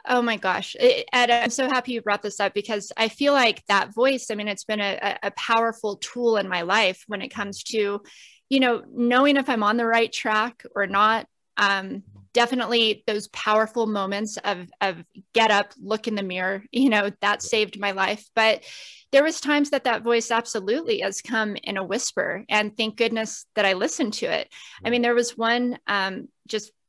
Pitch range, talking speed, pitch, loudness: 205-240 Hz, 200 wpm, 220 Hz, -23 LUFS